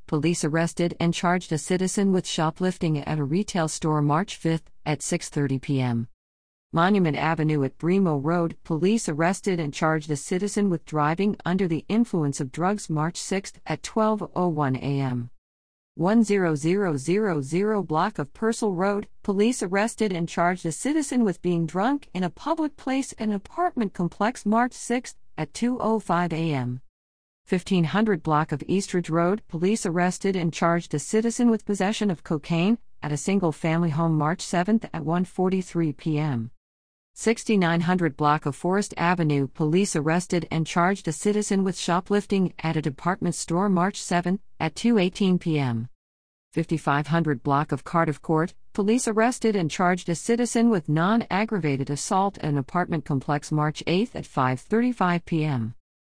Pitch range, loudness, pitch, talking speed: 155-200 Hz, -25 LUFS, 170 Hz, 145 wpm